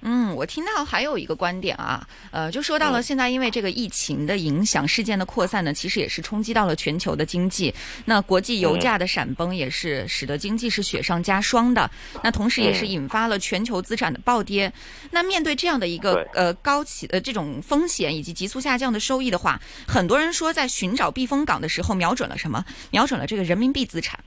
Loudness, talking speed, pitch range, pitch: -23 LUFS, 335 characters per minute, 180-250 Hz, 210 Hz